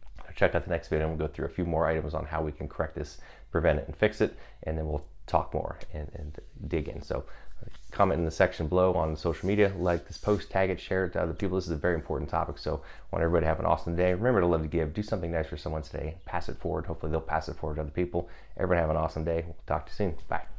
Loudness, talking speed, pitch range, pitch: -30 LUFS, 290 wpm, 80-90 Hz, 80 Hz